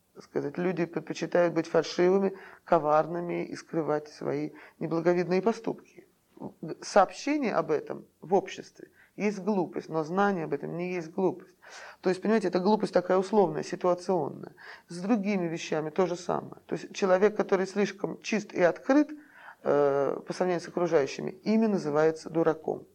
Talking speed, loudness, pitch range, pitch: 145 wpm, -28 LUFS, 165-200 Hz, 180 Hz